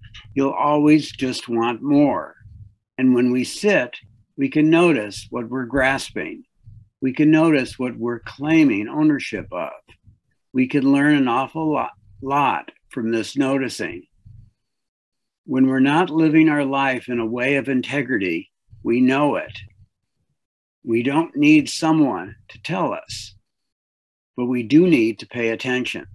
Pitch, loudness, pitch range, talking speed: 130 Hz, -20 LUFS, 110-145 Hz, 140 wpm